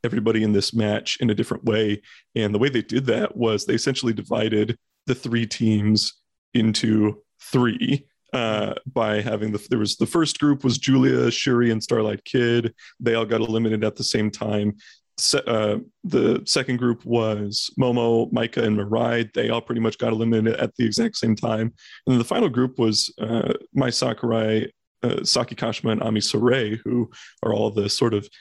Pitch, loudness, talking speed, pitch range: 115 Hz, -22 LUFS, 185 wpm, 105-120 Hz